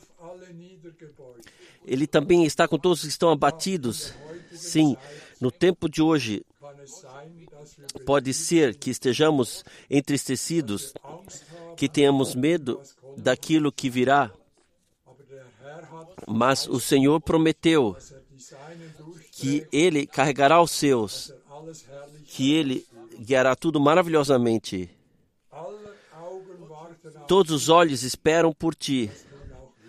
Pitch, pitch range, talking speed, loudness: 150 Hz, 135-165 Hz, 90 wpm, -23 LUFS